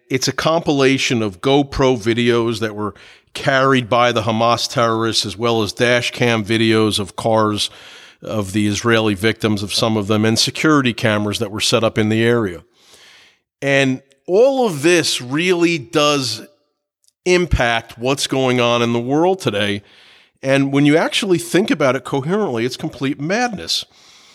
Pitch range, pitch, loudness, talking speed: 110-145 Hz, 120 Hz, -17 LUFS, 160 wpm